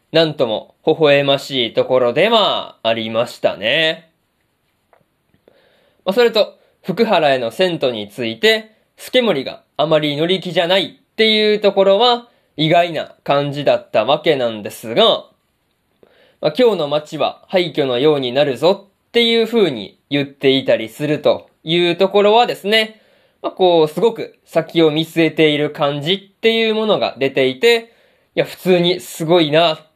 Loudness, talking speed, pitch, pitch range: -16 LUFS, 295 characters per minute, 175 Hz, 150-220 Hz